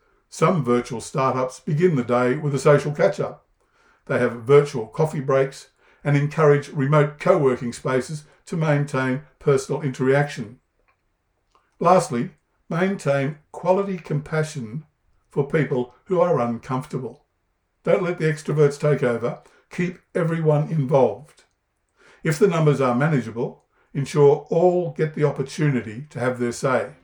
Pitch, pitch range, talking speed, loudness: 145 Hz, 130-160 Hz, 130 wpm, -22 LUFS